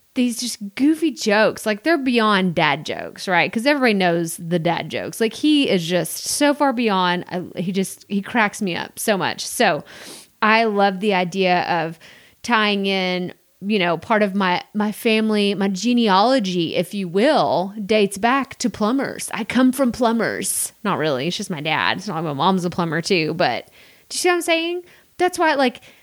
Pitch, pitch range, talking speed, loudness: 205 Hz, 180-240 Hz, 195 wpm, -19 LUFS